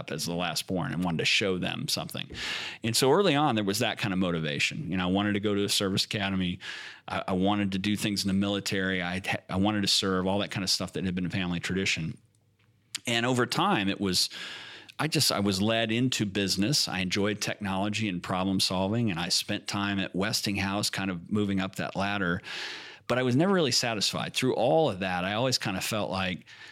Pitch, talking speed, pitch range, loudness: 100 Hz, 225 wpm, 95-110 Hz, -28 LUFS